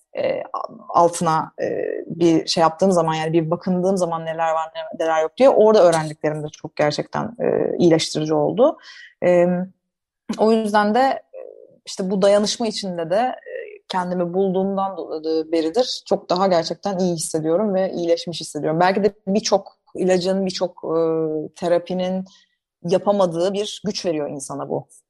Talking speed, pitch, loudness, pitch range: 125 wpm, 185 Hz, -20 LUFS, 165-210 Hz